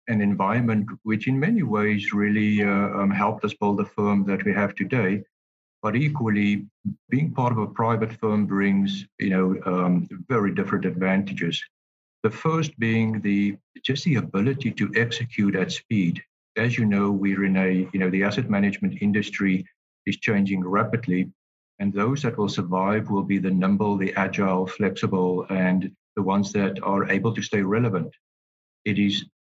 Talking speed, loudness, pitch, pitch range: 165 wpm, -24 LUFS, 100 Hz, 95-110 Hz